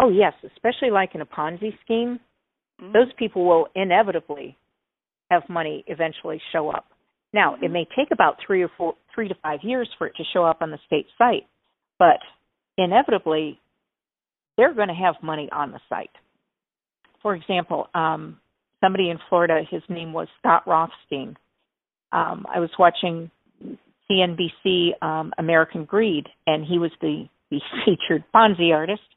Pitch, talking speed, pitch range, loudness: 175 Hz, 155 wpm, 160-200 Hz, -22 LUFS